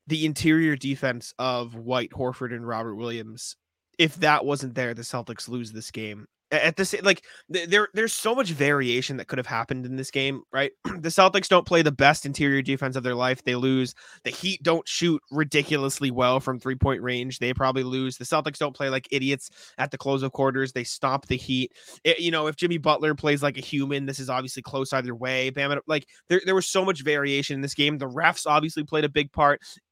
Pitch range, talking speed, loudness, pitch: 130-155 Hz, 220 wpm, -25 LUFS, 135 Hz